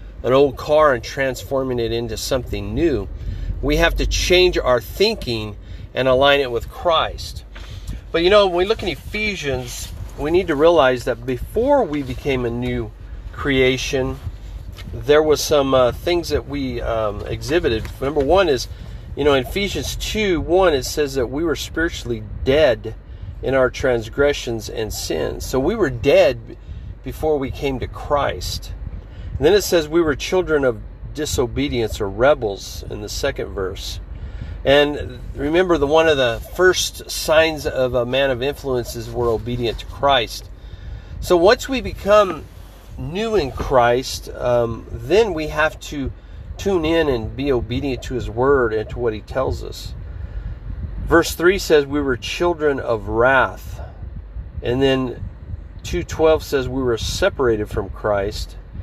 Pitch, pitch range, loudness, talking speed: 125 Hz, 100-145 Hz, -19 LUFS, 155 wpm